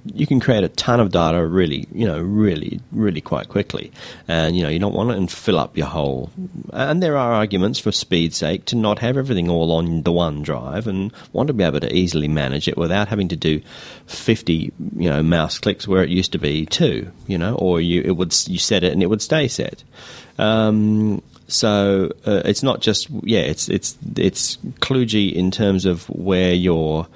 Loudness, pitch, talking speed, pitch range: -19 LUFS, 90 Hz, 210 wpm, 85-105 Hz